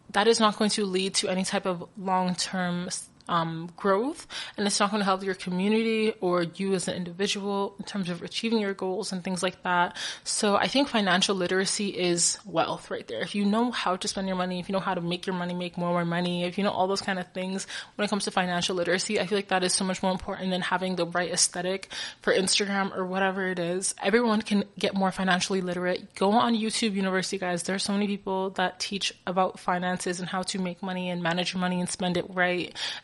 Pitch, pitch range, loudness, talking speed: 190 Hz, 180-200 Hz, -27 LUFS, 240 wpm